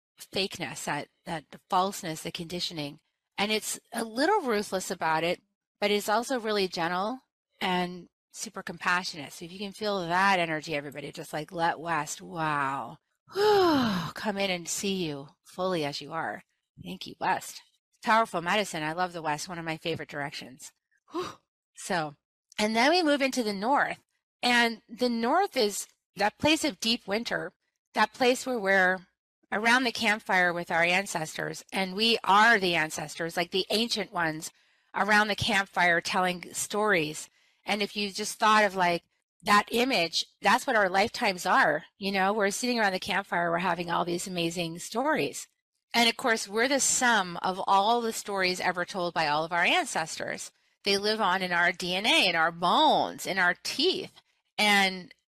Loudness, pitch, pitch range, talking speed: -27 LUFS, 195 Hz, 175-225 Hz, 170 wpm